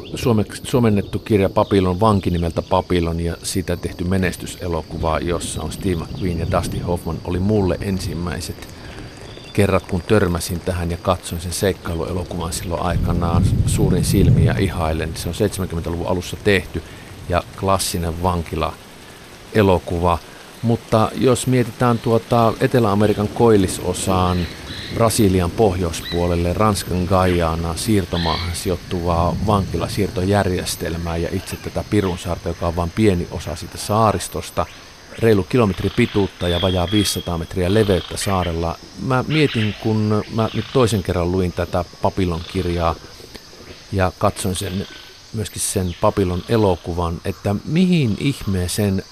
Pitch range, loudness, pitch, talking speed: 85-105 Hz, -20 LUFS, 95 Hz, 115 wpm